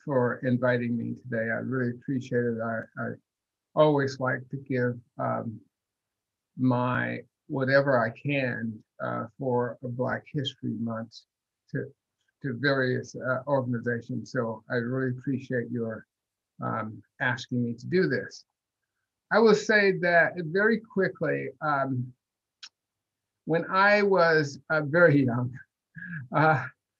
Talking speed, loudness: 120 wpm, -27 LUFS